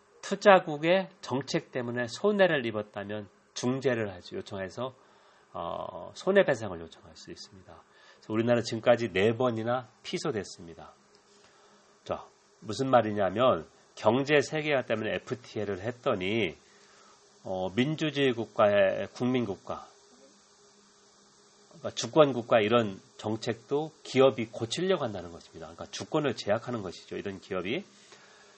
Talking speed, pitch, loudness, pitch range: 295 characters per minute, 125 Hz, -29 LUFS, 110-150 Hz